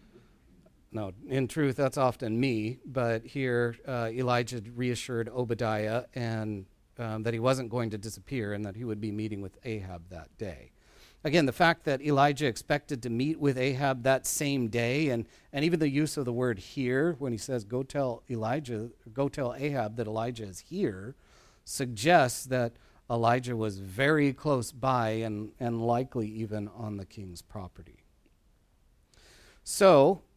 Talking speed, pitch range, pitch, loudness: 160 wpm, 110-135 Hz, 120 Hz, -30 LUFS